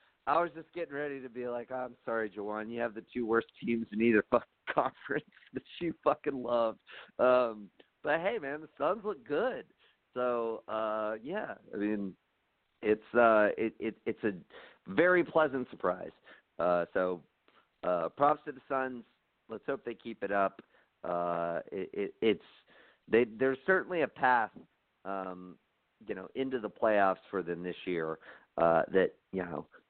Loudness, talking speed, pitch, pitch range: -33 LUFS, 170 wpm, 115 Hz, 100-130 Hz